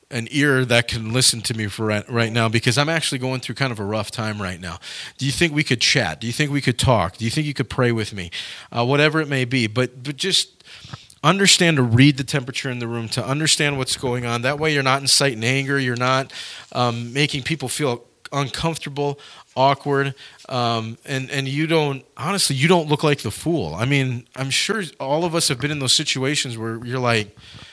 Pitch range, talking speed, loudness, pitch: 120-145 Hz, 245 wpm, -20 LUFS, 130 Hz